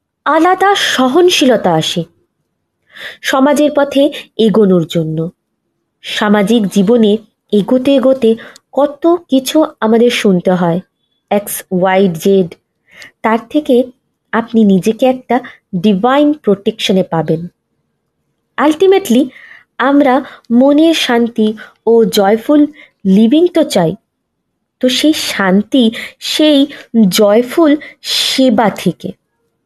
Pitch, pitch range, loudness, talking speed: 235 Hz, 205-285 Hz, -11 LUFS, 85 wpm